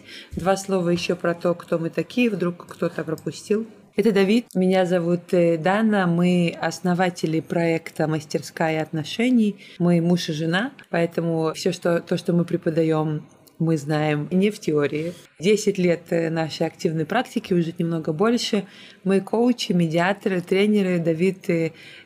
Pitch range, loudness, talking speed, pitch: 165-195 Hz, -22 LUFS, 135 wpm, 175 Hz